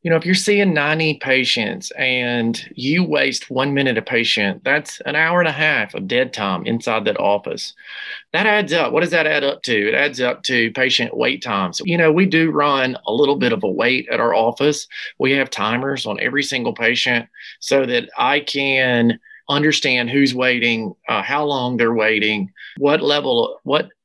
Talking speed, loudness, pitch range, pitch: 195 wpm, -17 LUFS, 125-155 Hz, 140 Hz